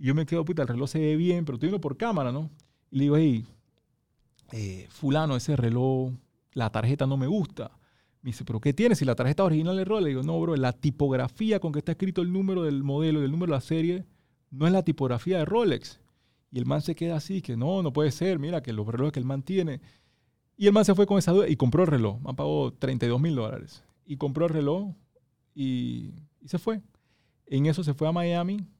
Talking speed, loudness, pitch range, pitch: 240 wpm, -27 LUFS, 130-170 Hz, 150 Hz